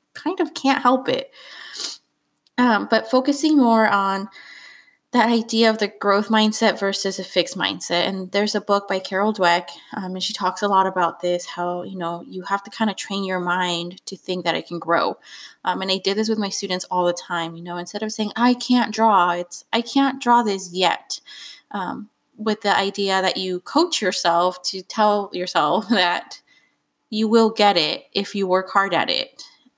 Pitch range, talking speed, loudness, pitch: 185-230 Hz, 200 wpm, -20 LUFS, 200 Hz